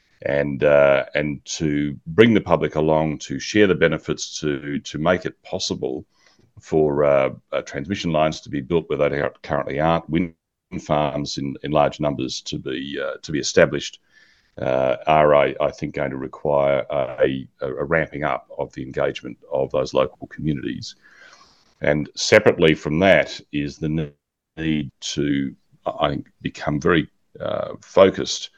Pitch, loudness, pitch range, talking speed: 75 Hz, -21 LUFS, 70-80 Hz, 155 wpm